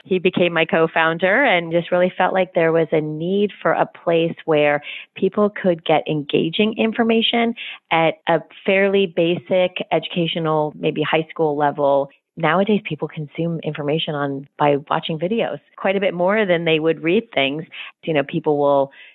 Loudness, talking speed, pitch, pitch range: -19 LUFS, 165 wpm, 165 Hz, 155-185 Hz